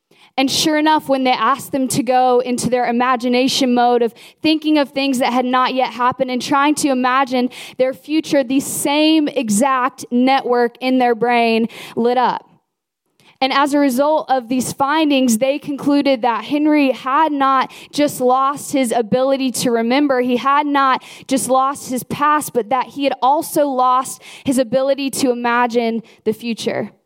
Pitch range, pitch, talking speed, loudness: 245-280 Hz, 260 Hz, 165 wpm, -16 LUFS